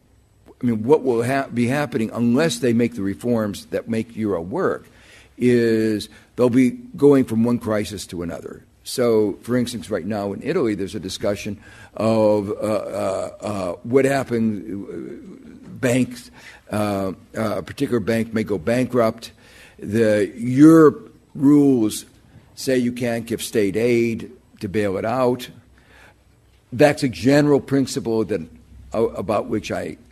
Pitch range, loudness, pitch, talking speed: 105-125 Hz, -20 LUFS, 115 Hz, 140 wpm